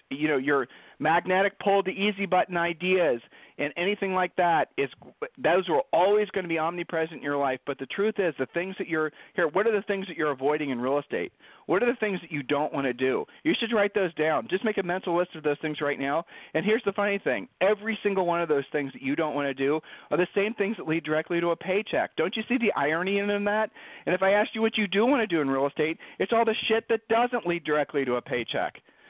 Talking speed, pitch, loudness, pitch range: 260 wpm, 175 Hz, -27 LUFS, 150-205 Hz